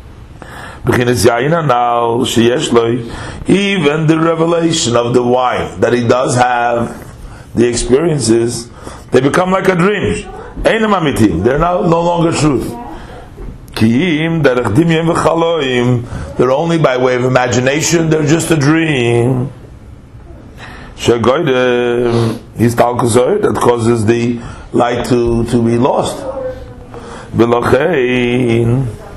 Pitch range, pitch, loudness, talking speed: 120-155 Hz, 125 Hz, -12 LUFS, 85 wpm